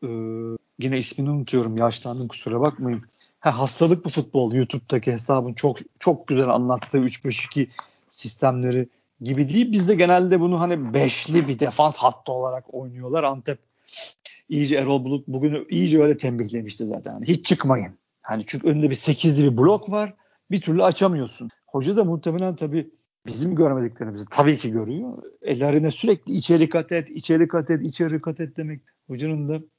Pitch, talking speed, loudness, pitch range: 145 Hz, 160 wpm, -22 LUFS, 125-165 Hz